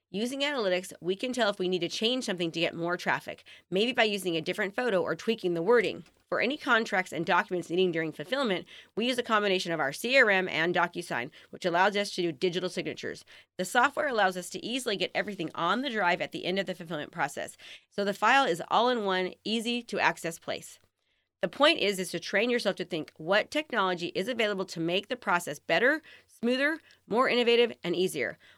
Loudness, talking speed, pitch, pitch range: -28 LUFS, 210 wpm, 190 Hz, 175-235 Hz